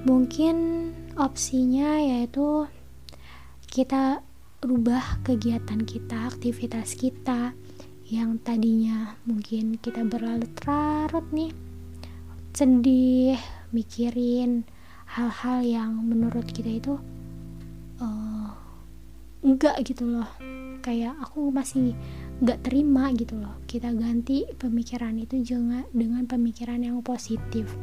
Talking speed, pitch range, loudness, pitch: 95 wpm, 225-260 Hz, -26 LUFS, 240 Hz